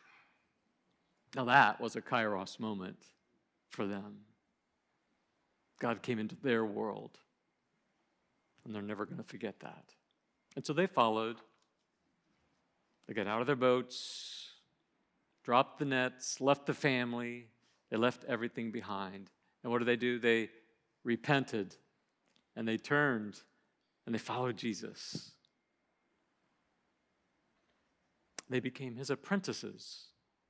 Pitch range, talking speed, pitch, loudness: 110-125 Hz, 115 wpm, 120 Hz, -35 LUFS